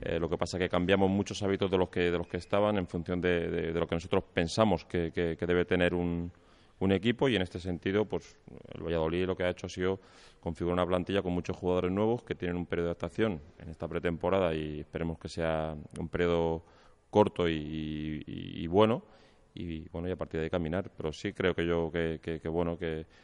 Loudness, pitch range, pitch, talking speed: -32 LUFS, 85-95 Hz, 90 Hz, 235 wpm